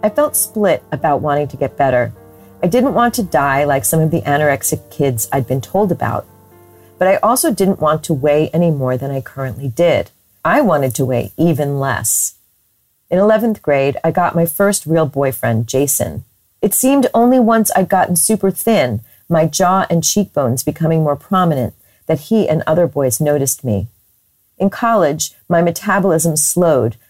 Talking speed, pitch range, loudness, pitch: 175 wpm, 130-185 Hz, -15 LUFS, 150 Hz